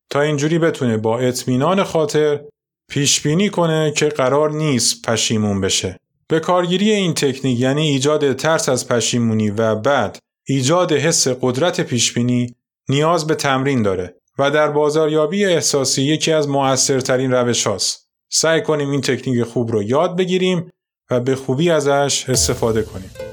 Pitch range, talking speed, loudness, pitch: 125-155 Hz, 145 wpm, -17 LUFS, 140 Hz